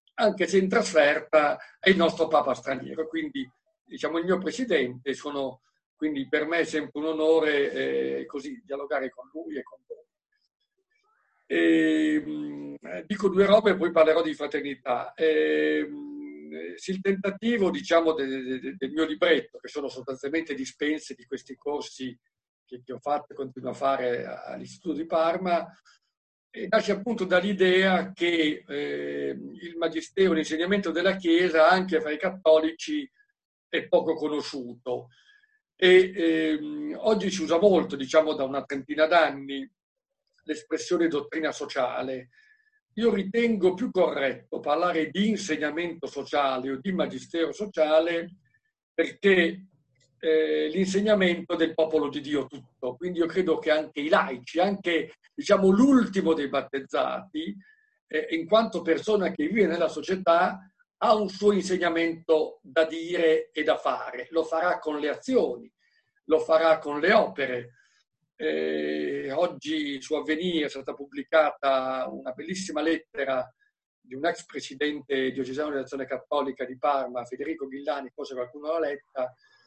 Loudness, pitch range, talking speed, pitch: -26 LUFS, 140-190 Hz, 140 wpm, 160 Hz